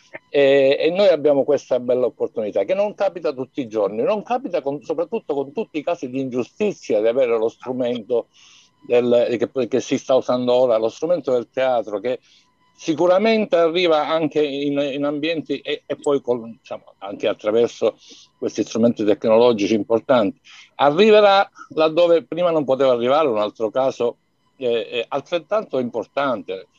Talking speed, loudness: 150 wpm, -20 LUFS